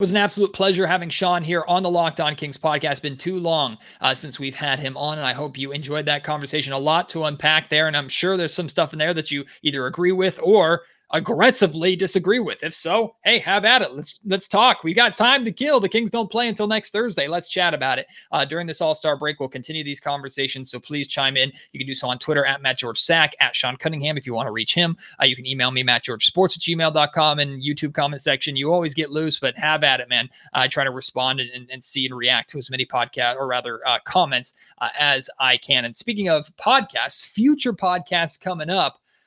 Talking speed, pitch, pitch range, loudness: 250 wpm, 155 Hz, 135-180 Hz, -20 LUFS